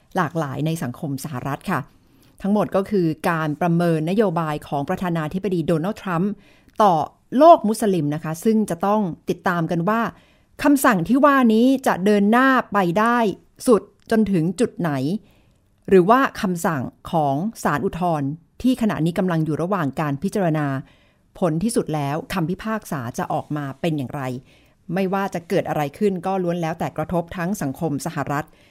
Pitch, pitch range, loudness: 175 Hz, 155-210 Hz, -21 LUFS